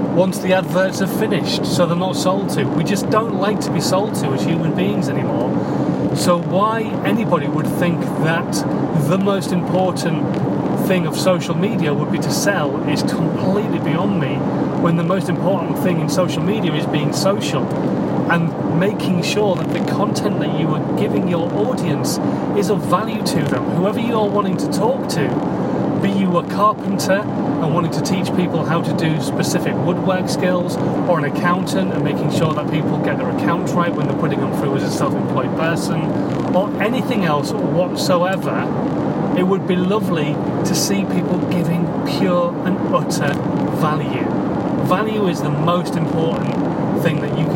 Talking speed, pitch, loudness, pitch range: 175 wpm, 180 Hz, -18 LUFS, 170-195 Hz